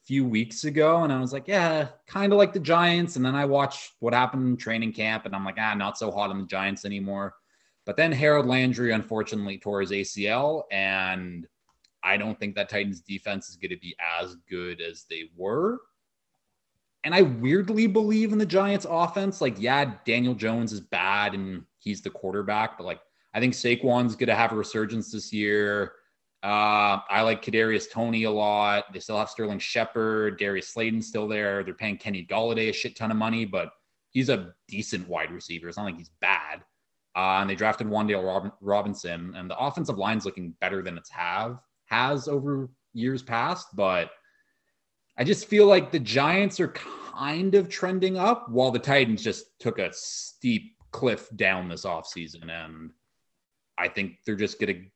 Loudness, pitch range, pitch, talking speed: -26 LUFS, 100-140 Hz, 110 Hz, 190 wpm